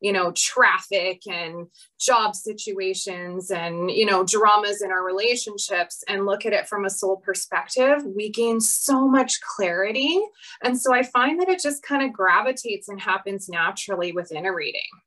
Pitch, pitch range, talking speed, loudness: 200 Hz, 190-240 Hz, 165 wpm, -22 LUFS